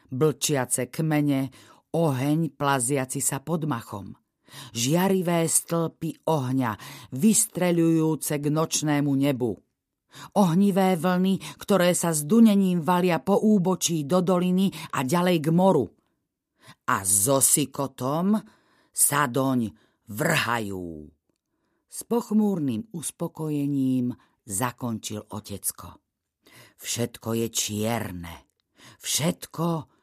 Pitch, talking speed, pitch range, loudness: 150 Hz, 90 wpm, 125-175 Hz, -24 LUFS